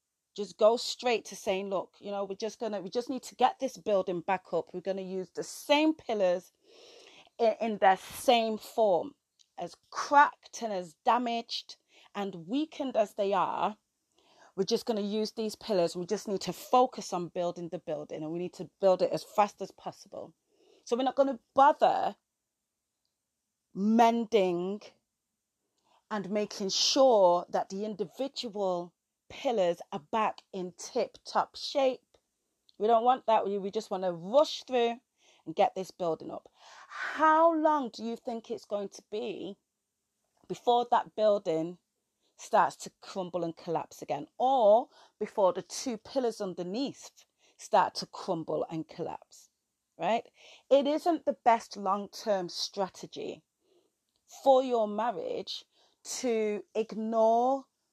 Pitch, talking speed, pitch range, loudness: 215 Hz, 150 wpm, 190-255 Hz, -30 LUFS